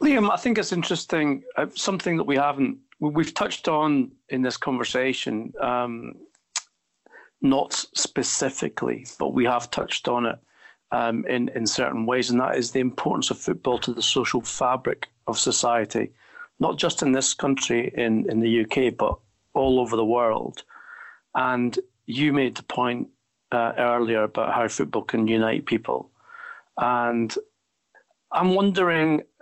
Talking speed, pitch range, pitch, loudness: 145 wpm, 120-185 Hz, 135 Hz, -24 LUFS